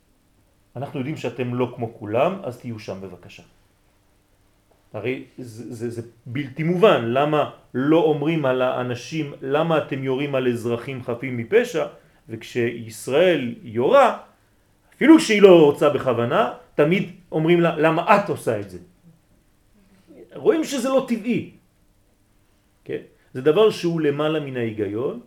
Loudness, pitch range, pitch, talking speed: -20 LUFS, 110-155 Hz, 130 Hz, 130 wpm